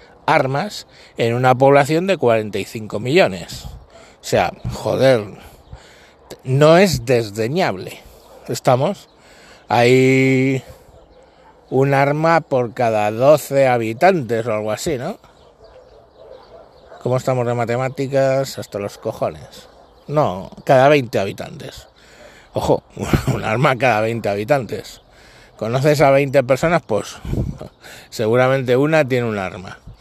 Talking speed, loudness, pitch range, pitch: 105 wpm, -17 LUFS, 115-140 Hz, 130 Hz